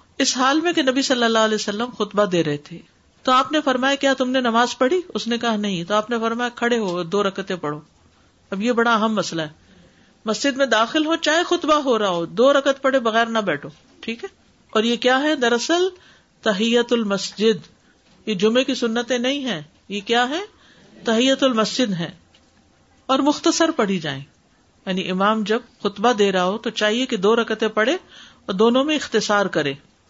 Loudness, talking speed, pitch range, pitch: -20 LUFS, 195 wpm, 205-265 Hz, 230 Hz